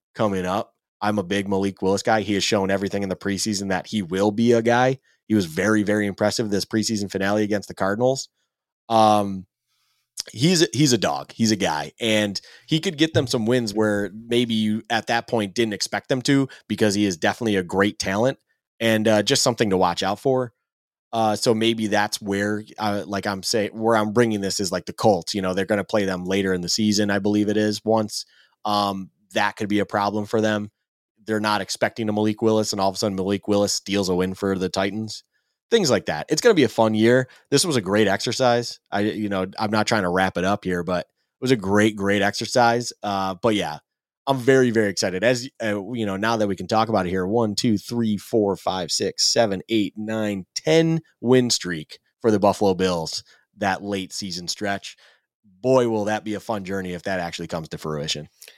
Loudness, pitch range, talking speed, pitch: -22 LUFS, 100-115 Hz, 220 wpm, 105 Hz